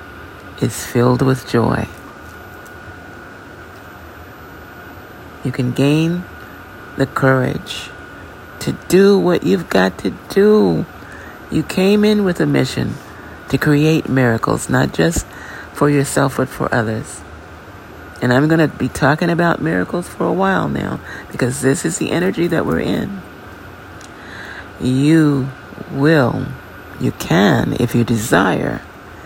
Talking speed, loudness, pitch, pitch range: 120 wpm, -16 LUFS, 120 Hz, 95-145 Hz